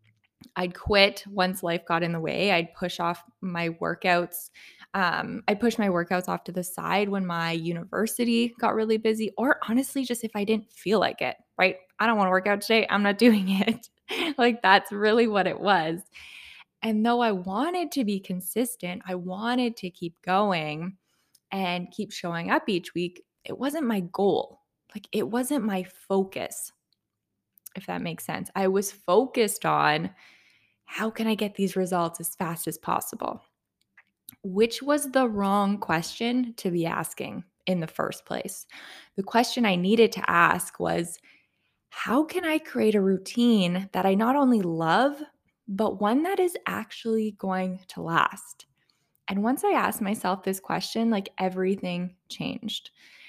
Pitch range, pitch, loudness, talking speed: 185-230 Hz, 200 Hz, -26 LUFS, 165 wpm